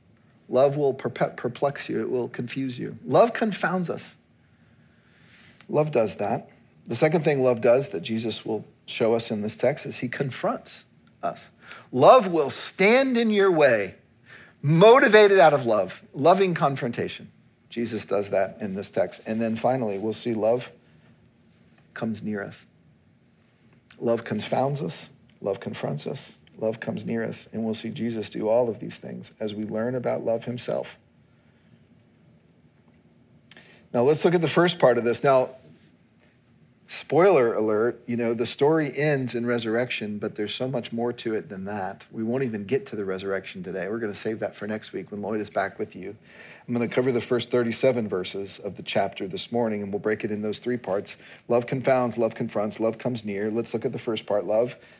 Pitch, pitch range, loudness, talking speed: 120 Hz, 110-135 Hz, -24 LUFS, 185 wpm